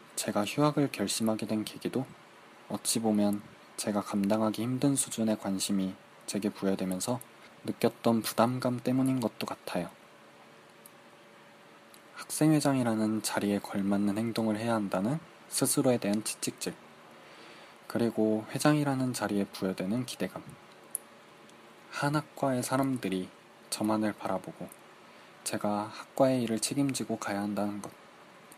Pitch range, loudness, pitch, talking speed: 105-130 Hz, -31 LUFS, 110 Hz, 275 characters per minute